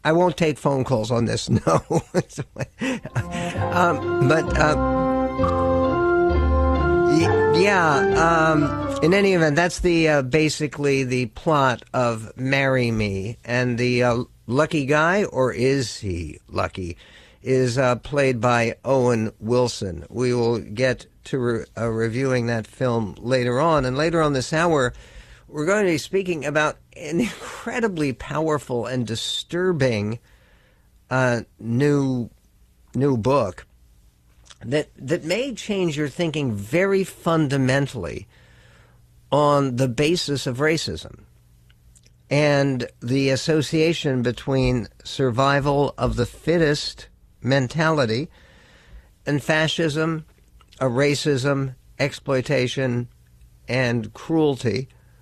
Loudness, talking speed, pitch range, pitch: -21 LUFS, 110 wpm, 115-150 Hz, 130 Hz